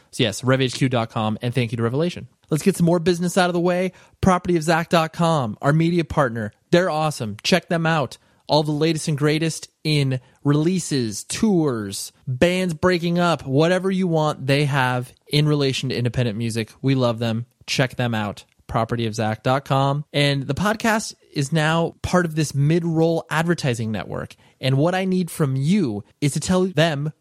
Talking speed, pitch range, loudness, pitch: 165 wpm, 125-170 Hz, -21 LUFS, 150 Hz